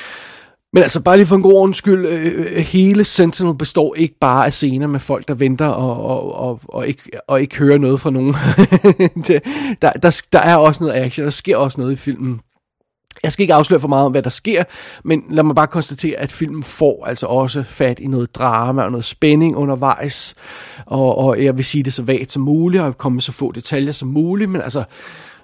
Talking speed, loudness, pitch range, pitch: 215 wpm, -15 LUFS, 130-165 Hz, 145 Hz